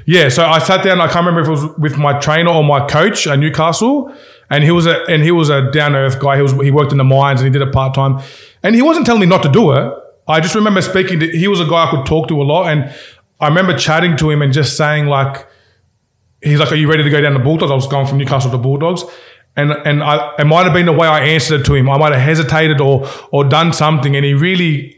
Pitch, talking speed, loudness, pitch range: 150 Hz, 285 wpm, -12 LUFS, 140-165 Hz